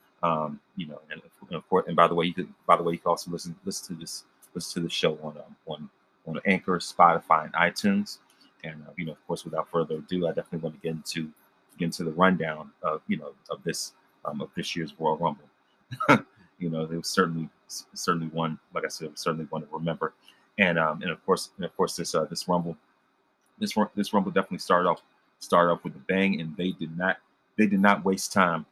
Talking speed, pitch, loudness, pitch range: 230 wpm, 85 Hz, -27 LUFS, 80-95 Hz